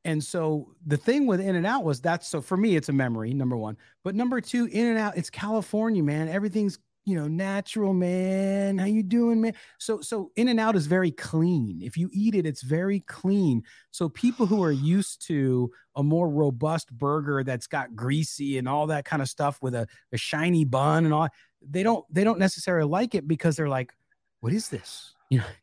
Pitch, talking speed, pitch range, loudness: 170 Hz, 200 wpm, 145-200 Hz, -26 LUFS